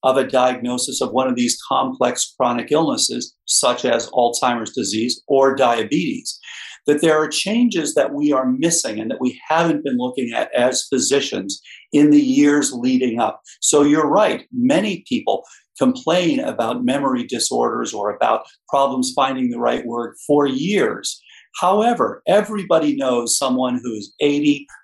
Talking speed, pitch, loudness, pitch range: 150 wpm, 135 Hz, -18 LUFS, 125-160 Hz